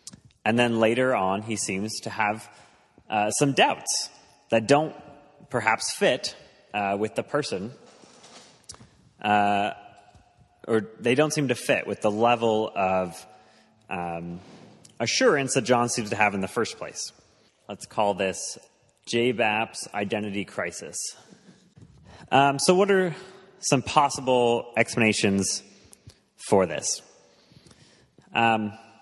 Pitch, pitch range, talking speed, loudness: 110 Hz, 105-125 Hz, 120 wpm, -25 LUFS